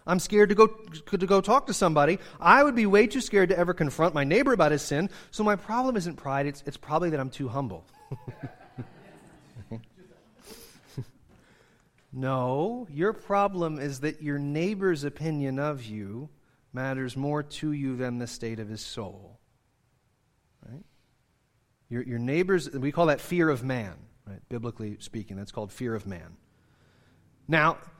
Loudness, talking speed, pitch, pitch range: -26 LUFS, 160 wpm, 140 Hz, 120-175 Hz